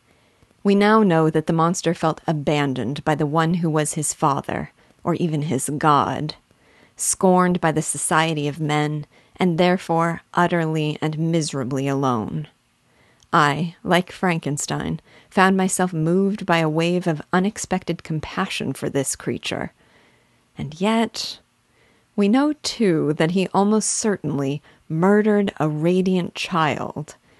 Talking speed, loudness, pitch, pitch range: 130 wpm, -21 LUFS, 165 Hz, 150-185 Hz